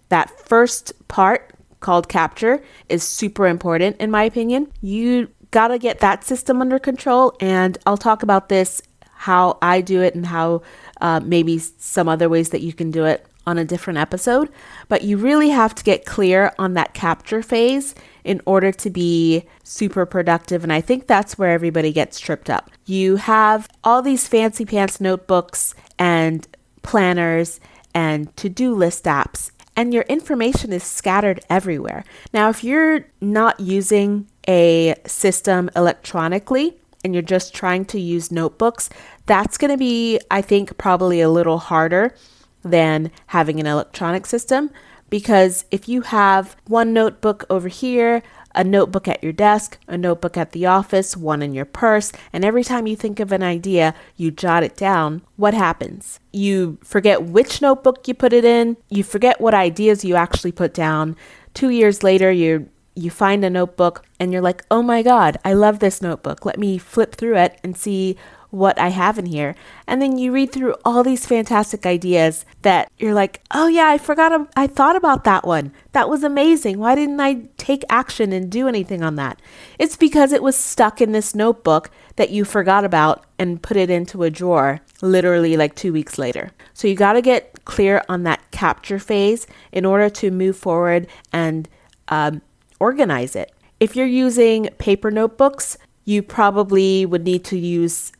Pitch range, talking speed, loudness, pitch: 175-230 Hz, 175 wpm, -17 LUFS, 195 Hz